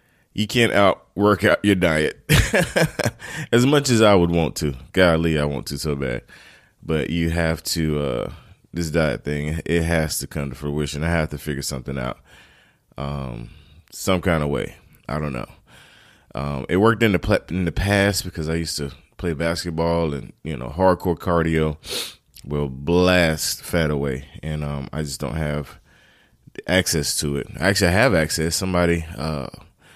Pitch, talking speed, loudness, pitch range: 80 Hz, 175 wpm, -21 LUFS, 75-85 Hz